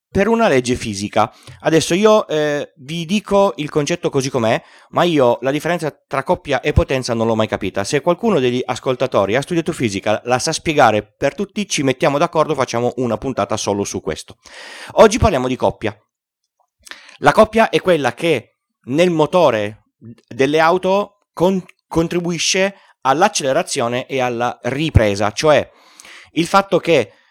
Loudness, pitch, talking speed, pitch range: -17 LUFS, 145 Hz, 150 wpm, 120-175 Hz